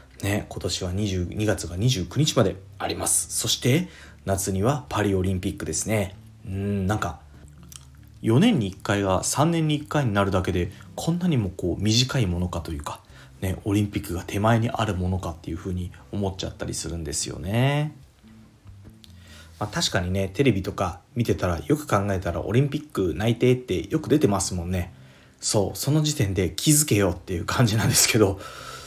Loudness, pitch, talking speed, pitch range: -24 LUFS, 100 Hz, 345 characters per minute, 90-115 Hz